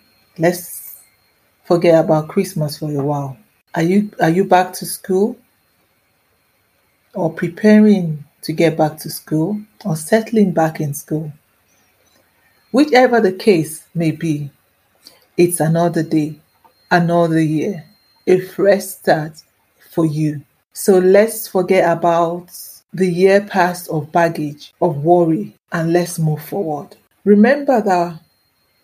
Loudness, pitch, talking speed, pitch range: -16 LUFS, 175 Hz, 120 wpm, 160-195 Hz